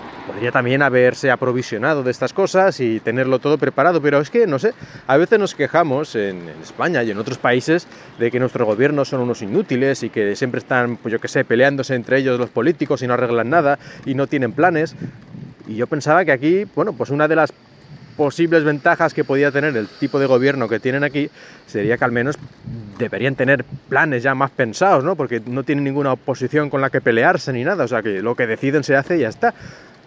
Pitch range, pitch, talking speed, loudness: 125-150 Hz, 135 Hz, 220 wpm, -18 LUFS